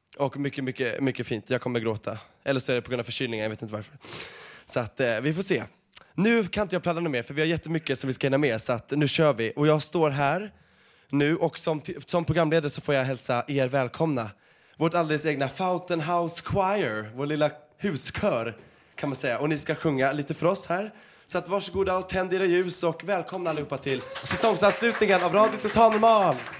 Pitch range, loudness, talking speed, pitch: 135-180 Hz, -26 LUFS, 225 wpm, 155 Hz